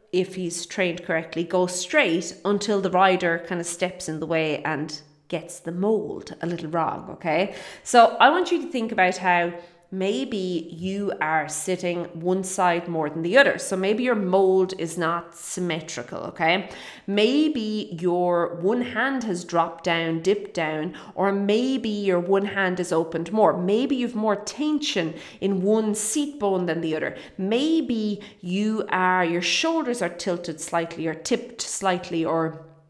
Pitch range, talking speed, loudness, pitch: 170-210 Hz, 160 wpm, -24 LUFS, 185 Hz